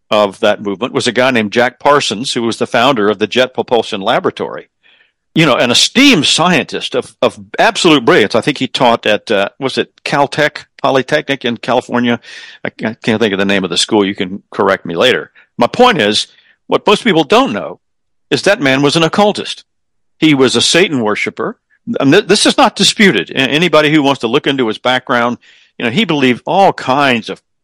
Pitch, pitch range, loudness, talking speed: 130 Hz, 115-150 Hz, -12 LUFS, 200 wpm